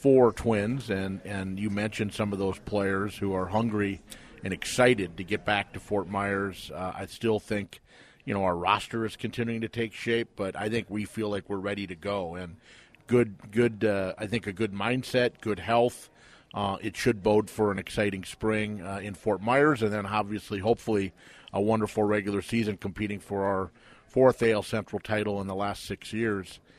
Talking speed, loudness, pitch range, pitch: 195 wpm, -29 LUFS, 100-115 Hz, 105 Hz